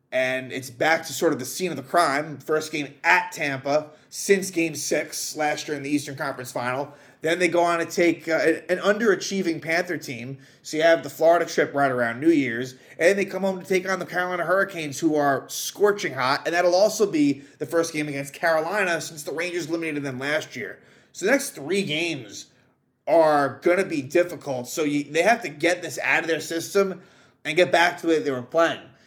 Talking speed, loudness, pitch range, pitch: 220 wpm, -23 LUFS, 140-175 Hz, 160 Hz